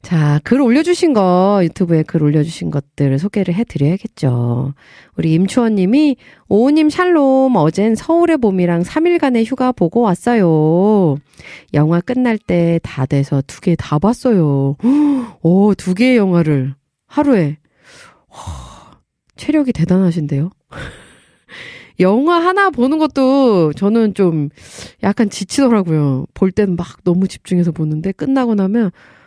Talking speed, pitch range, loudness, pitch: 260 characters per minute, 160-250 Hz, -14 LUFS, 195 Hz